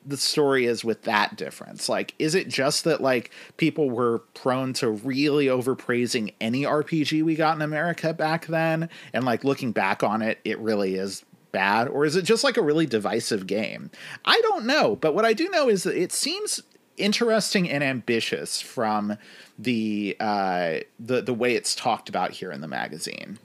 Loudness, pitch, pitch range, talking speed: -24 LUFS, 140 Hz, 115-160 Hz, 185 wpm